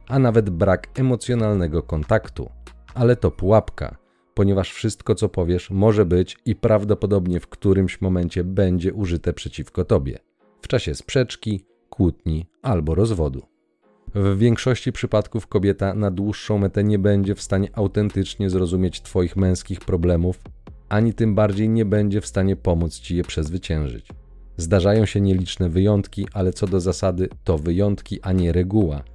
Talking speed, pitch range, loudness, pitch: 140 wpm, 90-105 Hz, -21 LUFS, 95 Hz